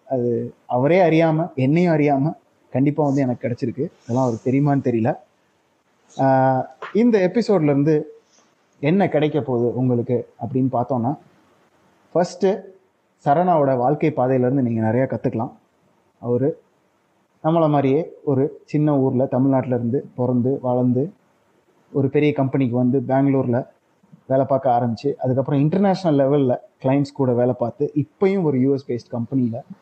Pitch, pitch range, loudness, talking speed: 135 Hz, 125-150 Hz, -20 LUFS, 115 wpm